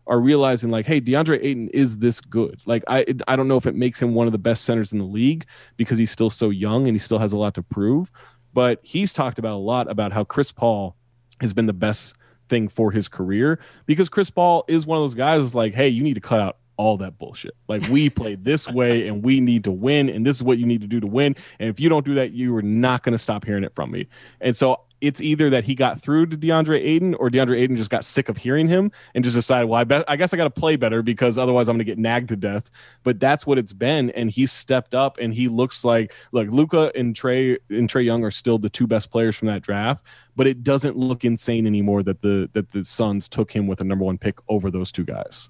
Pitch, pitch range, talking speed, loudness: 120 Hz, 110-135 Hz, 270 wpm, -21 LUFS